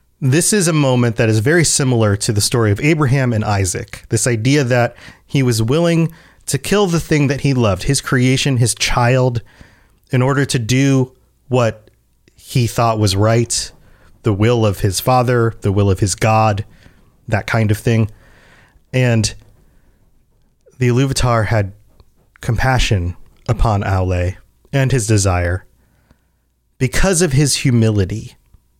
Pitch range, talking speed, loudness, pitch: 105-130 Hz, 145 wpm, -16 LUFS, 115 Hz